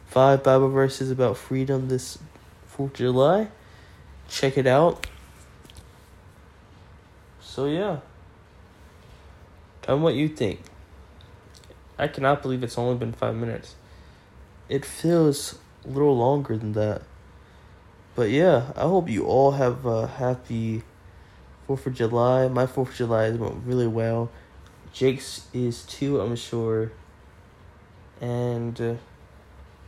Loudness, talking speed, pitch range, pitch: -24 LUFS, 120 wpm, 90-130 Hz, 115 Hz